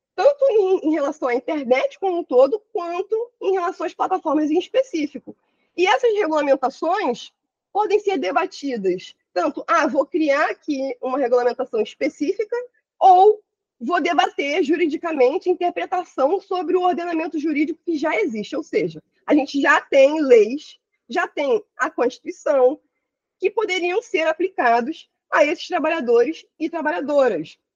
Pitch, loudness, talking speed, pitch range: 330 Hz, -20 LUFS, 140 wpm, 285-380 Hz